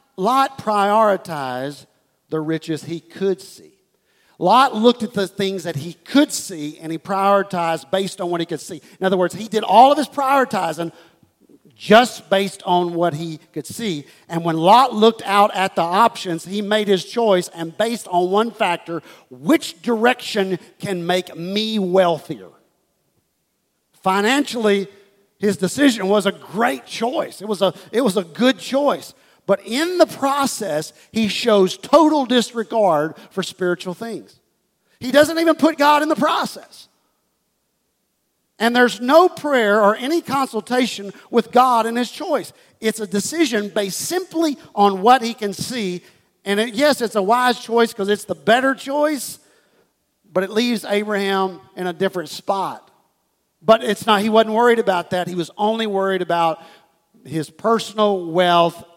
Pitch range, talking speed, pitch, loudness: 180-235 Hz, 160 wpm, 205 Hz, -18 LUFS